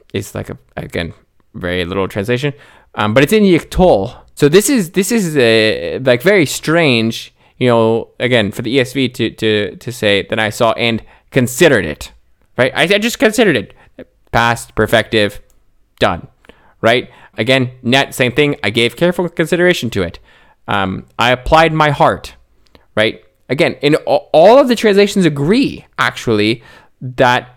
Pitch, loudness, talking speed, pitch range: 125 Hz, -13 LUFS, 155 wpm, 110-160 Hz